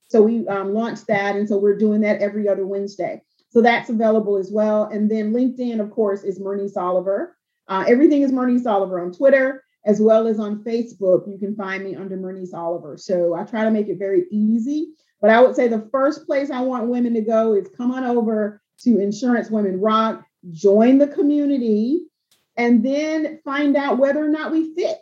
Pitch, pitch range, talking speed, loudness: 220 Hz, 200-255 Hz, 205 wpm, -19 LUFS